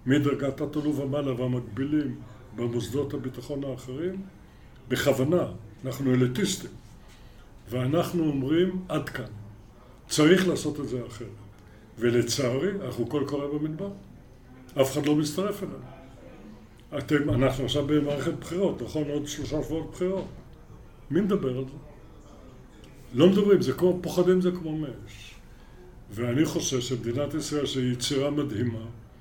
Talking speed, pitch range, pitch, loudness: 120 wpm, 125-155 Hz, 140 Hz, -27 LUFS